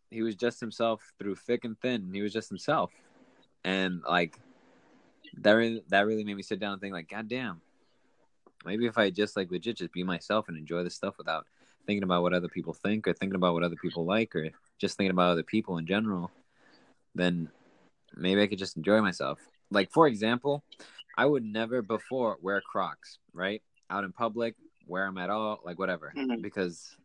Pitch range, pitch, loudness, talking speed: 90-115 Hz, 100 Hz, -31 LUFS, 195 wpm